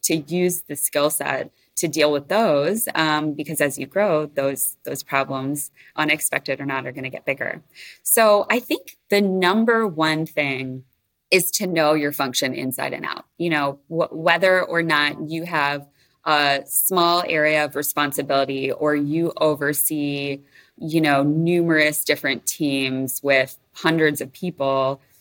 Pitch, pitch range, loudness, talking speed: 150 Hz, 140-170 Hz, -21 LUFS, 155 wpm